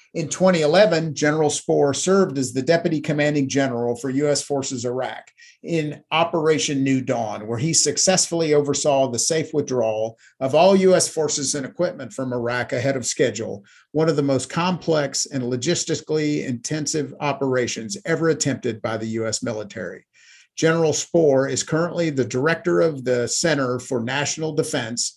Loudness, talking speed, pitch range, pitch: -21 LUFS, 150 wpm, 130-160 Hz, 145 Hz